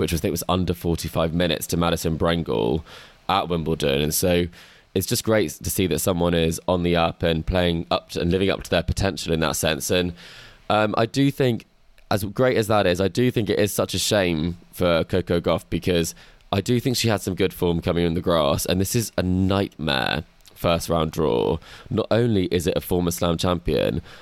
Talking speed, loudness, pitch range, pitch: 225 wpm, -22 LUFS, 85-95 Hz, 90 Hz